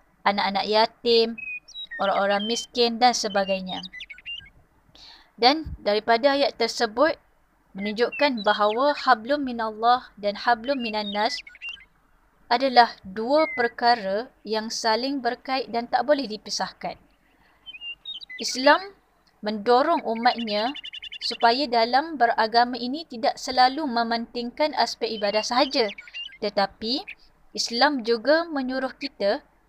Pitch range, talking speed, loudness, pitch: 220-275 Hz, 90 wpm, -23 LUFS, 240 Hz